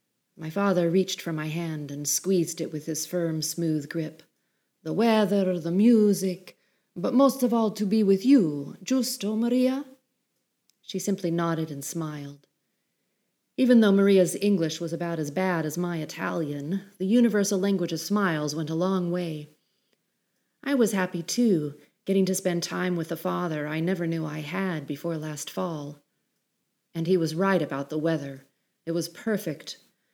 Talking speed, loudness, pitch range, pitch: 165 wpm, -26 LUFS, 160-200 Hz, 180 Hz